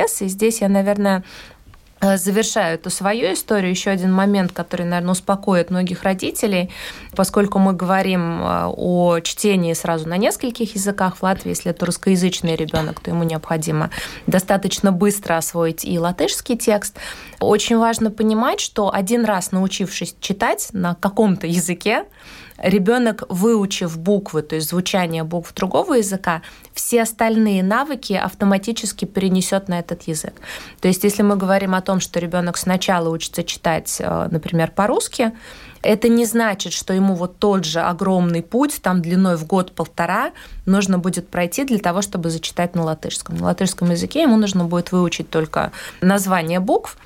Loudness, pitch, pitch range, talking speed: -19 LUFS, 190 Hz, 175-205 Hz, 145 wpm